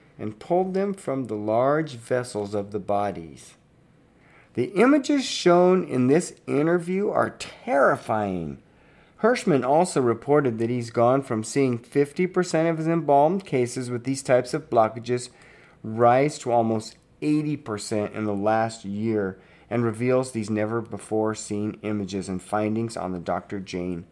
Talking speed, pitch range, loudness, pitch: 140 wpm, 105-150 Hz, -24 LUFS, 120 Hz